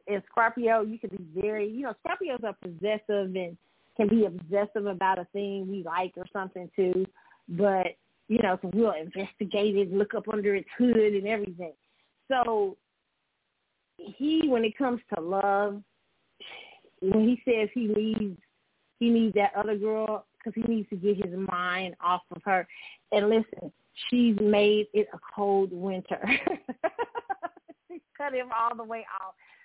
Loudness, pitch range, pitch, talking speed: -28 LUFS, 190-230 Hz, 210 Hz, 155 wpm